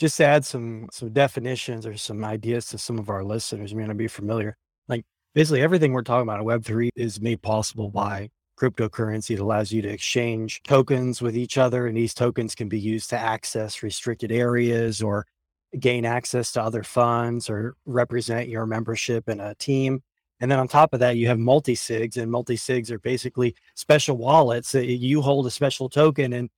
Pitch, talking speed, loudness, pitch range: 120 Hz, 195 wpm, -24 LUFS, 110-125 Hz